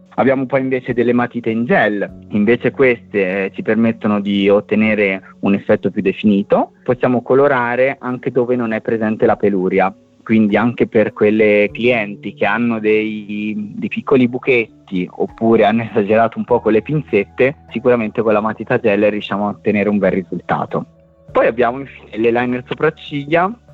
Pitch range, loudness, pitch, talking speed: 105-125 Hz, -16 LUFS, 110 Hz, 155 wpm